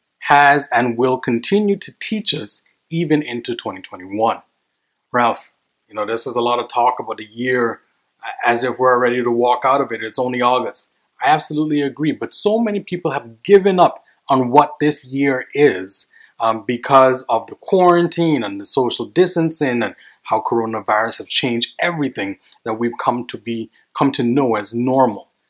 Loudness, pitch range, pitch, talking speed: -17 LUFS, 120-150 Hz, 130 Hz, 175 wpm